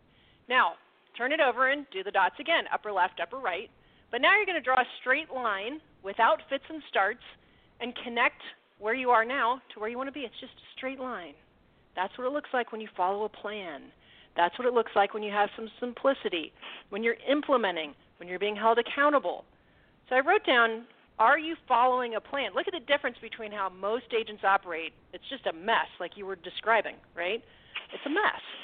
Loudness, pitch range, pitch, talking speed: -28 LUFS, 205-270 Hz, 235 Hz, 210 wpm